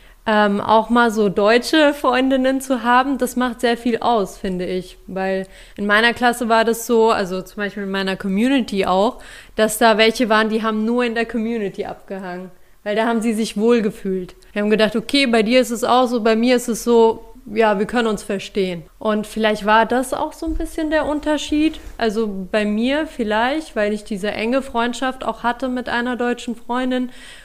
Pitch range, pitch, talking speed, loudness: 210-245 Hz, 225 Hz, 200 wpm, -18 LUFS